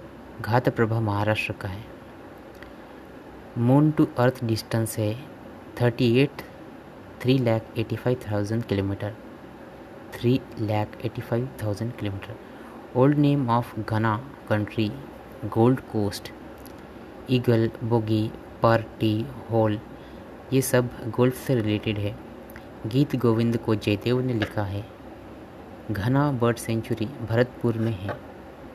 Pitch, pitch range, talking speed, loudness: 115 Hz, 110-125 Hz, 115 wpm, -25 LUFS